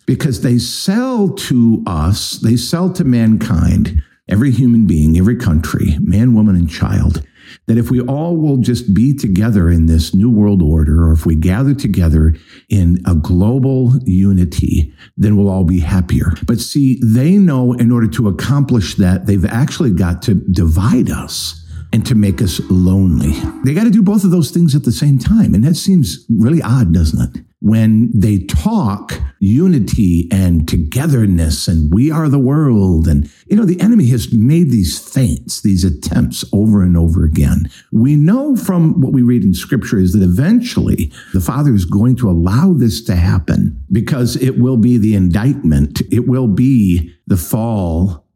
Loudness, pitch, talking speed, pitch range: -13 LUFS, 105 Hz, 175 wpm, 90-130 Hz